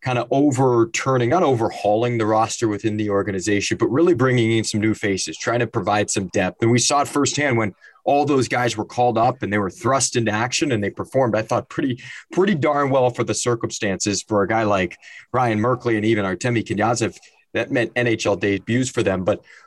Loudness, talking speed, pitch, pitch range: -20 LUFS, 210 wpm, 115 Hz, 105-125 Hz